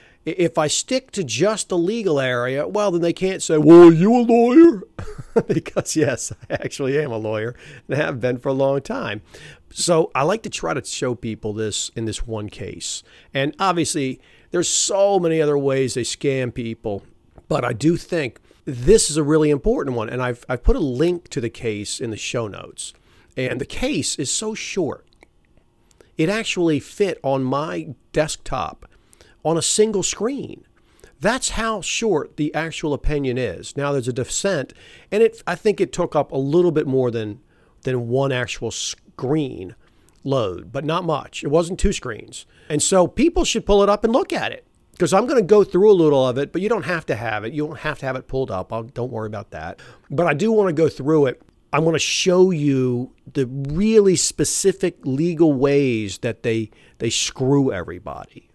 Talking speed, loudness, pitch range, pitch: 195 wpm, -20 LUFS, 125-175 Hz, 150 Hz